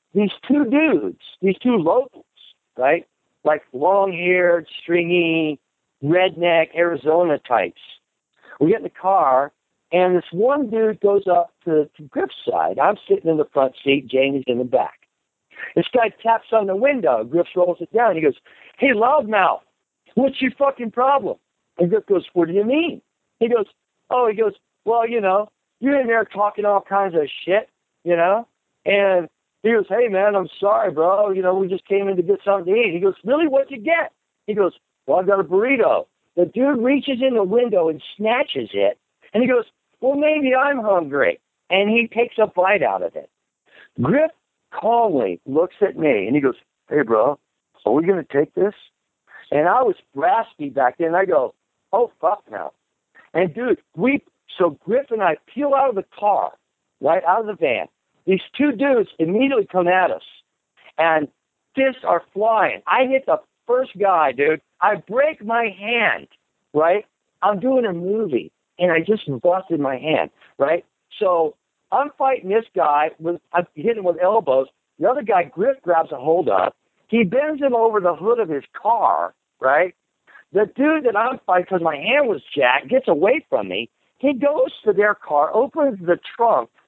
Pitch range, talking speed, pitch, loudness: 175-265 Hz, 185 wpm, 210 Hz, -19 LUFS